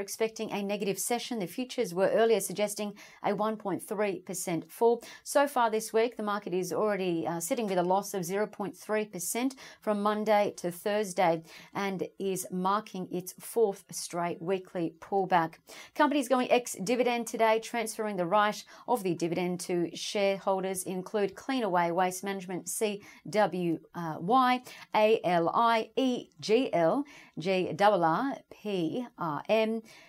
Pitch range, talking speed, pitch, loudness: 180-225 Hz, 140 wpm, 200 Hz, -30 LUFS